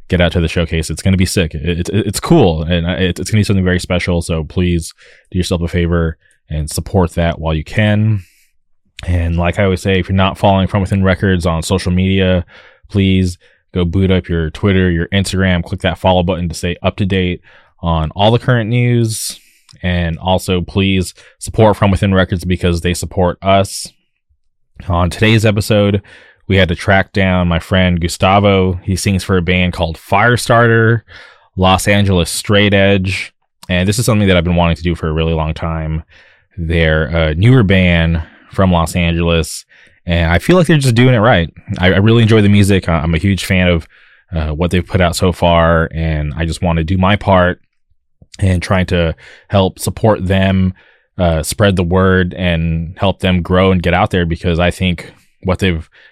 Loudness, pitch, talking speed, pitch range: -14 LUFS, 90 Hz, 195 wpm, 85-100 Hz